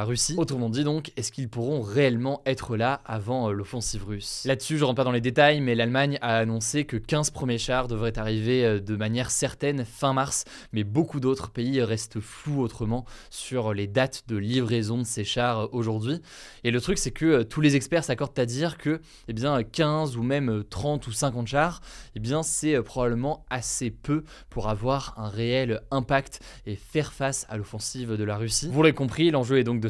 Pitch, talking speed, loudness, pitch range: 125 Hz, 195 wpm, -26 LUFS, 115-140 Hz